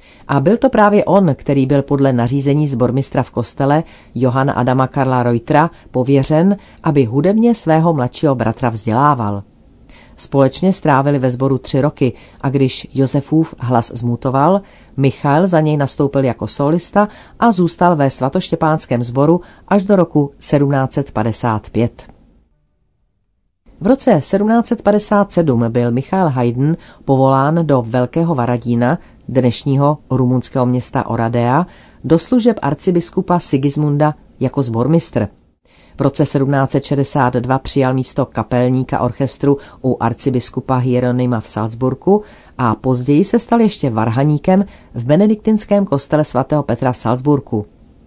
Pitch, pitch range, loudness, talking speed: 140 Hz, 125-160 Hz, -15 LUFS, 115 wpm